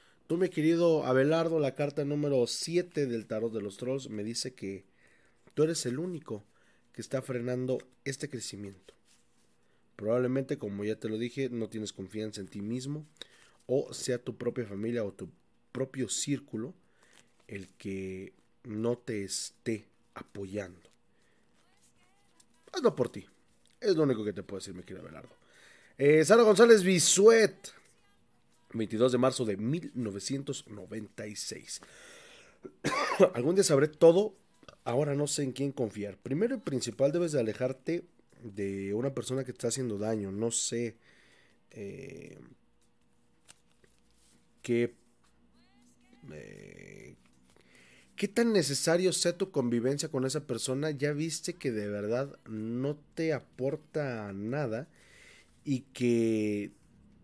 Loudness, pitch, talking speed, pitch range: -30 LUFS, 125 Hz, 130 wpm, 110-150 Hz